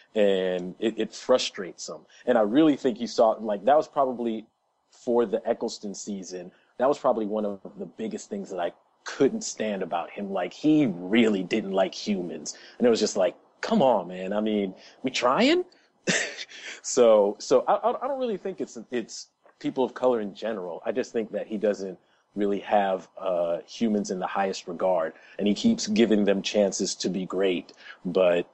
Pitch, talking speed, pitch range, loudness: 110 Hz, 185 wpm, 100-135 Hz, -26 LUFS